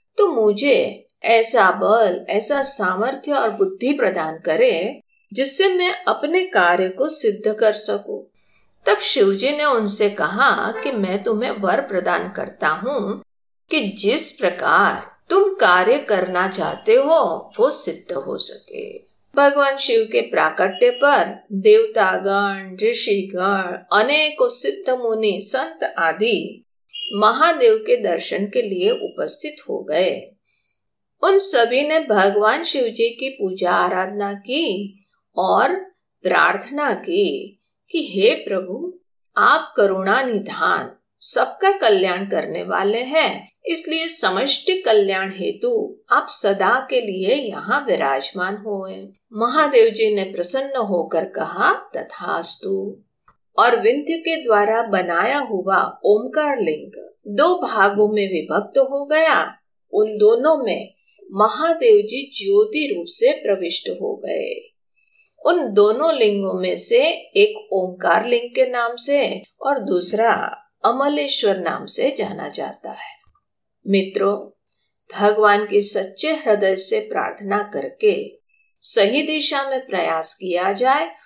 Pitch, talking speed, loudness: 260 Hz, 120 wpm, -17 LUFS